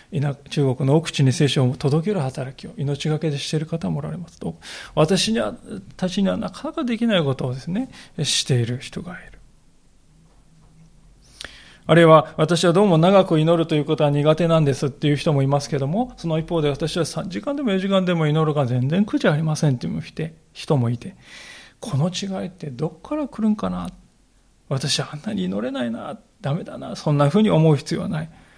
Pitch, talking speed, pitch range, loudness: 160 Hz, 365 characters per minute, 145-185 Hz, -21 LUFS